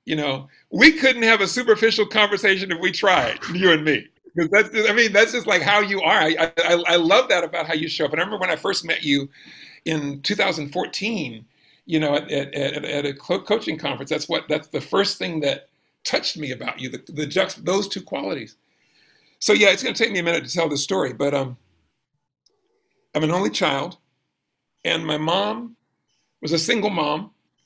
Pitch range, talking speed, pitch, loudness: 145-210 Hz, 210 wpm, 175 Hz, -20 LUFS